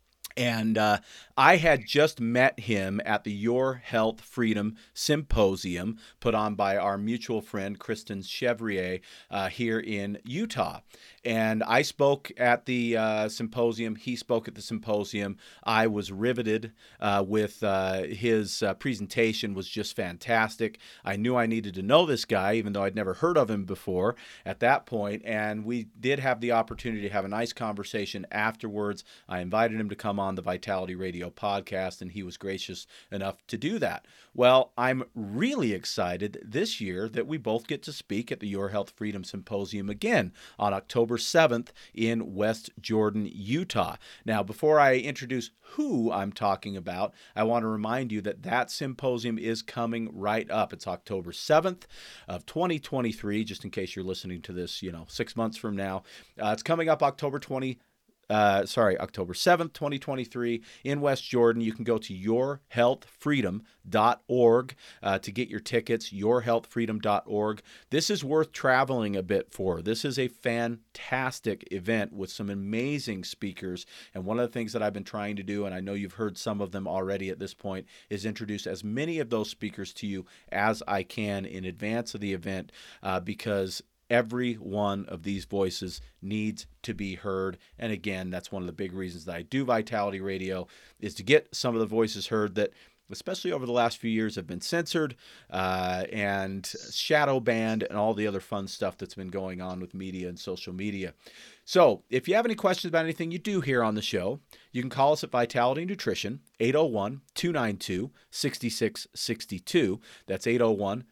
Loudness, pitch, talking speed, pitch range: -29 LUFS, 110 Hz, 180 wpm, 100-120 Hz